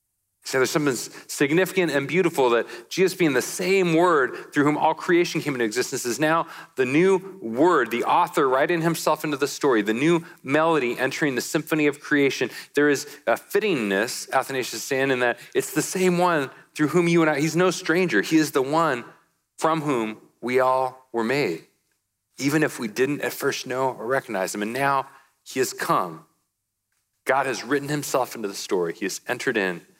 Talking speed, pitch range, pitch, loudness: 190 wpm, 130-165 Hz, 150 Hz, -23 LUFS